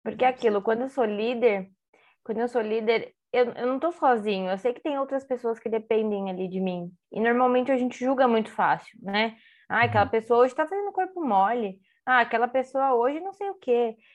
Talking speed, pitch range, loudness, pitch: 215 wpm, 220-260 Hz, -25 LUFS, 240 Hz